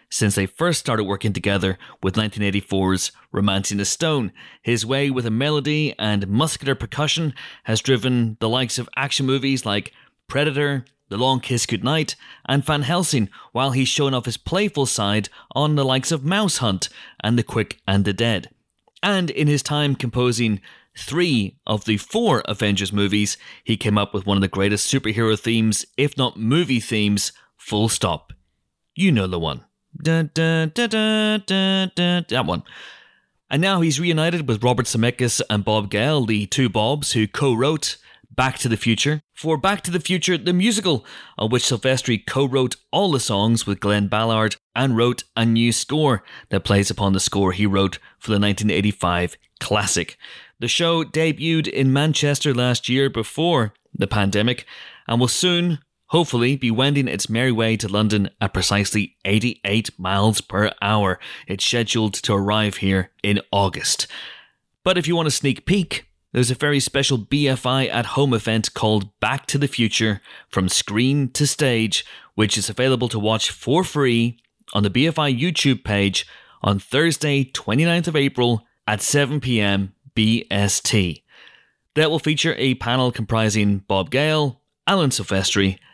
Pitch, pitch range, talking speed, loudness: 120 Hz, 105-145 Hz, 165 wpm, -20 LUFS